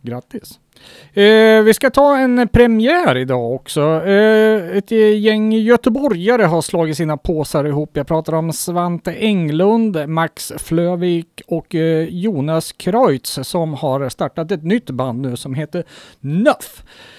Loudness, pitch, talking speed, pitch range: -15 LUFS, 175 Hz, 125 wpm, 155-220 Hz